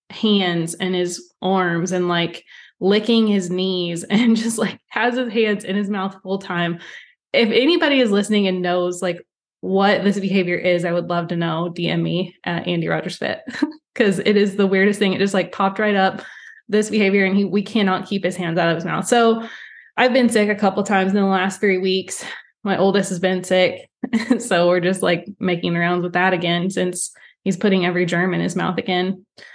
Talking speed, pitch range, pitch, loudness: 210 wpm, 180-210 Hz, 190 Hz, -19 LUFS